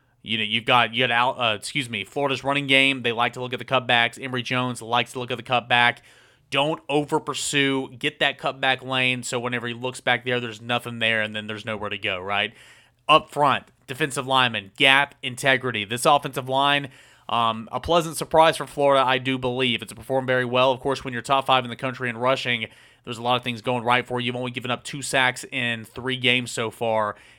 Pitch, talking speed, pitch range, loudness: 125 Hz, 225 wpm, 120-135 Hz, -22 LUFS